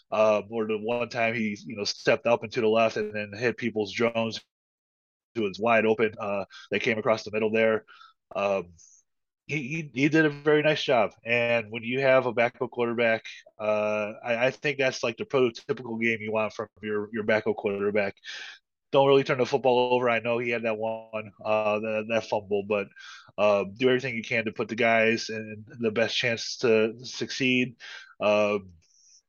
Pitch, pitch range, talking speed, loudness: 115 Hz, 110-120 Hz, 195 wpm, -26 LUFS